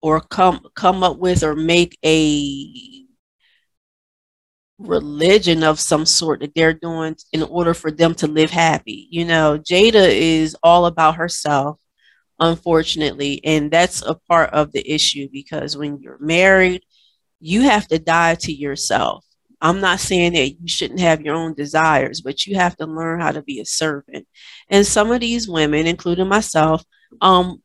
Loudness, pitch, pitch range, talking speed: -16 LUFS, 165 Hz, 155-180 Hz, 165 wpm